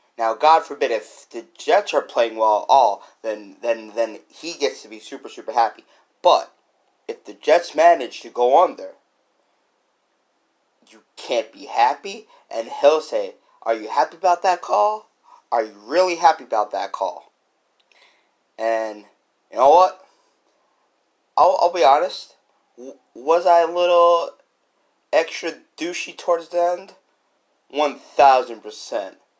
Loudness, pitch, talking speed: -19 LUFS, 170 Hz, 135 wpm